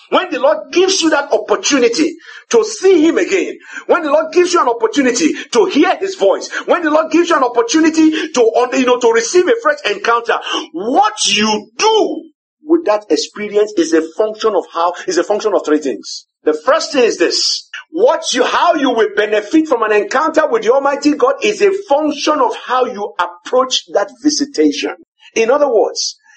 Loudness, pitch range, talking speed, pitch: -13 LUFS, 230-365 Hz, 190 wpm, 300 Hz